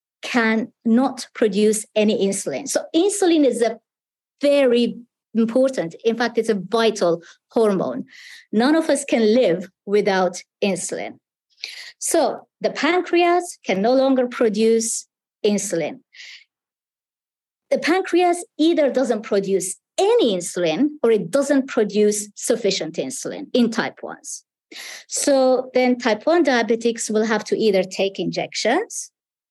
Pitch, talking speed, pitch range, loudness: 235 Hz, 120 wpm, 215-285 Hz, -20 LUFS